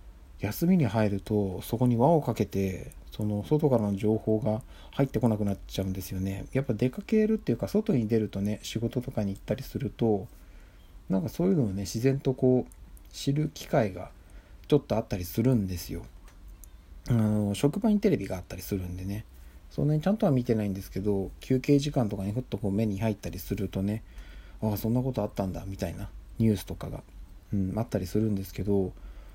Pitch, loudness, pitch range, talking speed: 105 Hz, -29 LUFS, 95-125 Hz, 405 characters per minute